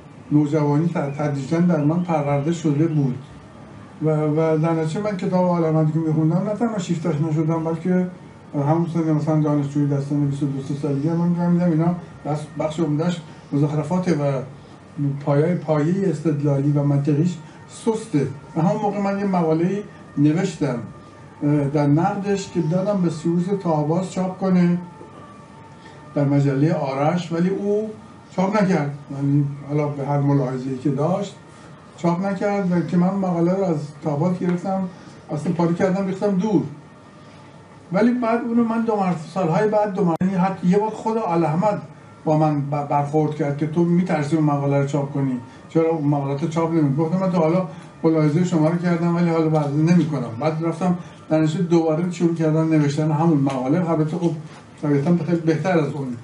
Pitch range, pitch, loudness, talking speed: 150-180 Hz, 160 Hz, -21 LUFS, 165 wpm